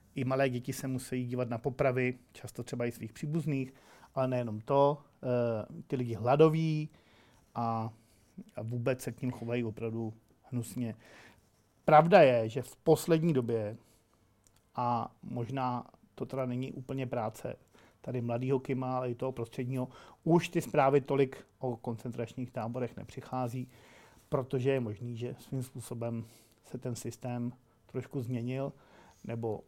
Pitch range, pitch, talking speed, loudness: 115-135 Hz, 125 Hz, 140 wpm, -33 LUFS